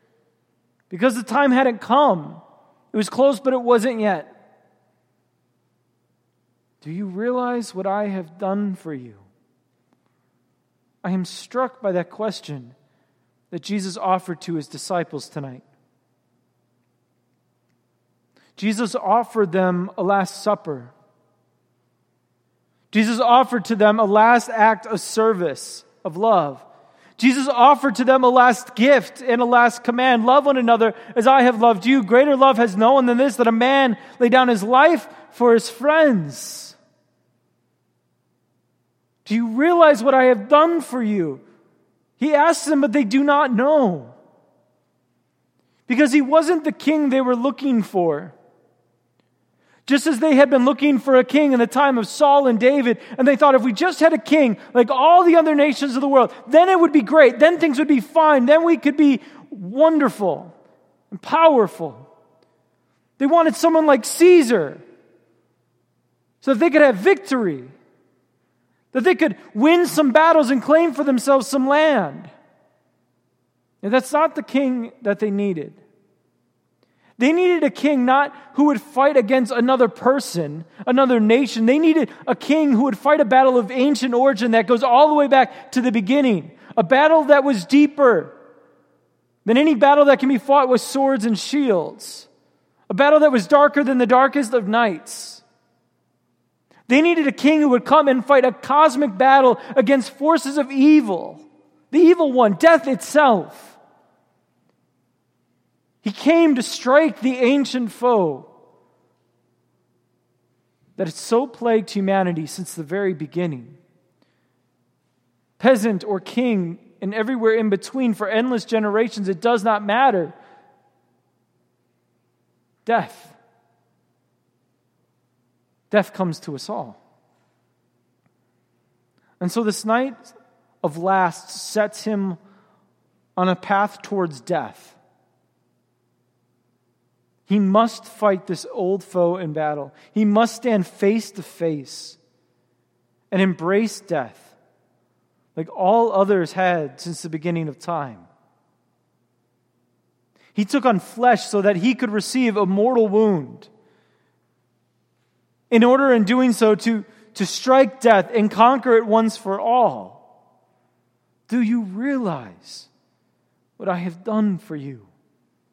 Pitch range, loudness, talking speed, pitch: 180-270 Hz, -17 LUFS, 140 wpm, 230 Hz